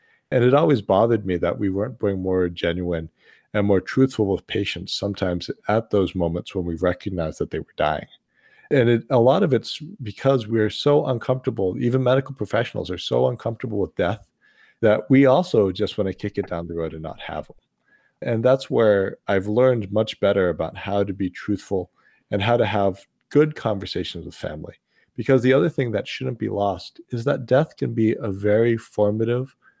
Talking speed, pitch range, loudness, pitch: 195 wpm, 95-130 Hz, -22 LUFS, 105 Hz